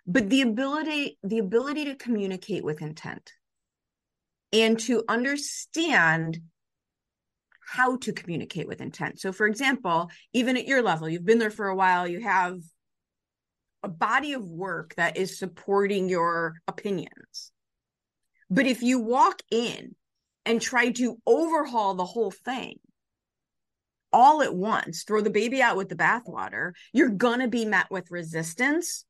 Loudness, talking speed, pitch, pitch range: -25 LUFS, 145 wpm, 220 Hz, 185-255 Hz